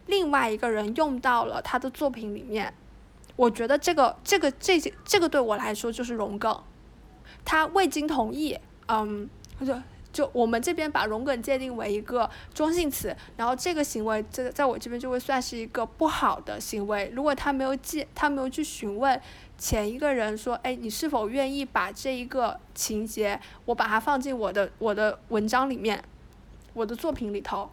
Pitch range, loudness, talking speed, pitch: 220-285 Hz, -27 LUFS, 275 characters per minute, 250 Hz